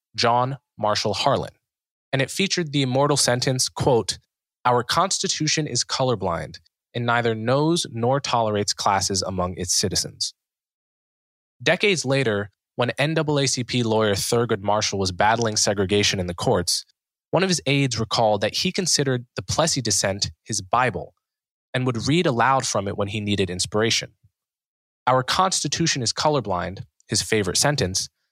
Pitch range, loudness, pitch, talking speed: 105-140 Hz, -22 LUFS, 120 Hz, 140 wpm